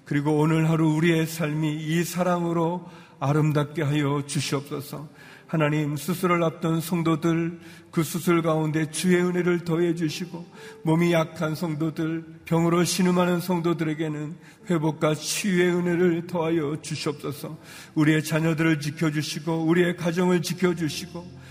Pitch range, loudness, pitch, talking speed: 155-175 Hz, -24 LUFS, 165 Hz, 320 characters per minute